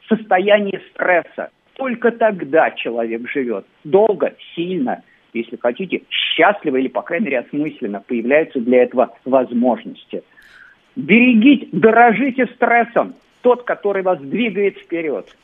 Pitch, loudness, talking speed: 195 Hz, -17 LUFS, 110 wpm